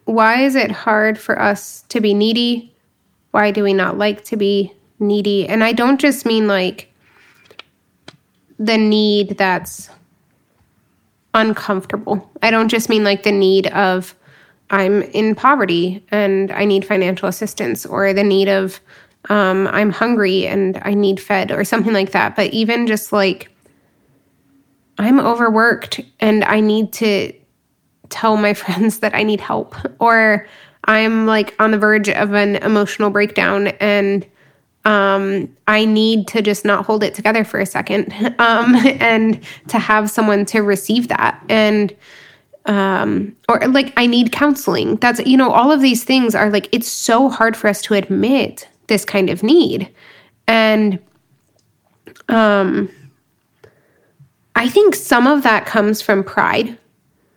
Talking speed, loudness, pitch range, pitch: 150 wpm, -15 LUFS, 200-225 Hz, 210 Hz